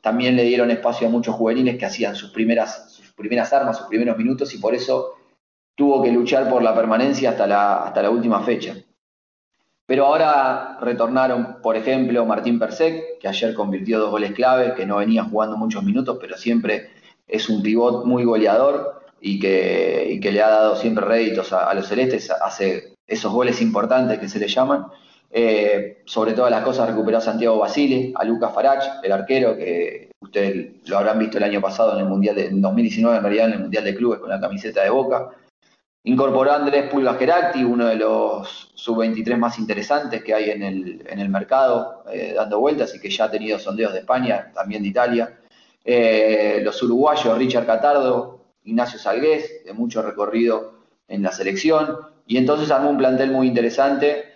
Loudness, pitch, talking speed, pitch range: -19 LUFS, 115 Hz, 190 wpm, 110-135 Hz